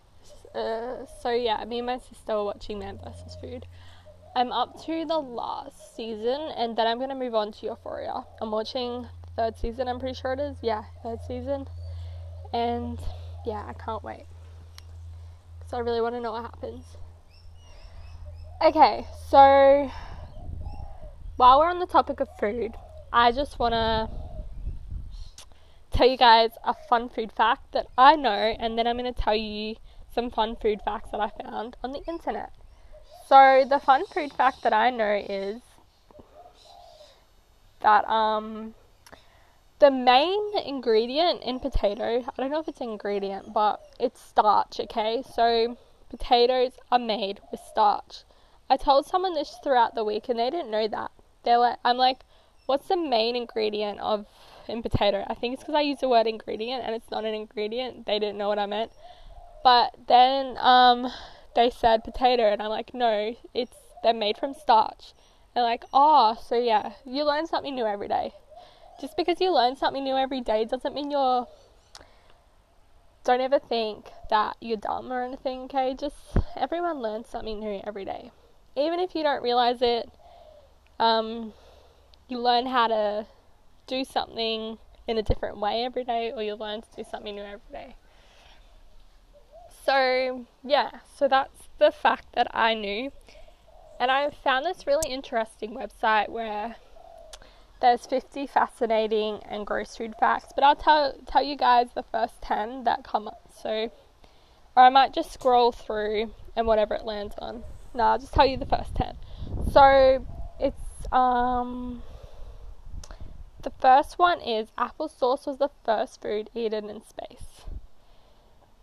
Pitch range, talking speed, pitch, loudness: 215-275 Hz, 165 wpm, 240 Hz, -25 LUFS